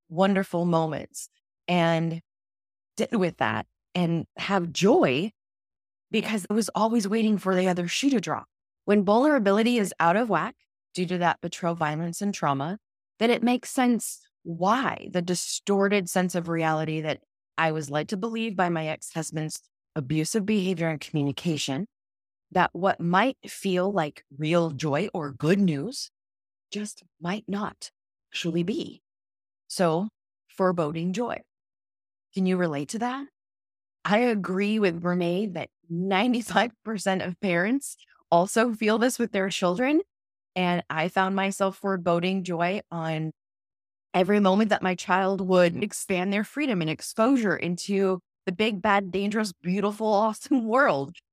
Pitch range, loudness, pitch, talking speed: 165-210 Hz, -26 LUFS, 185 Hz, 140 wpm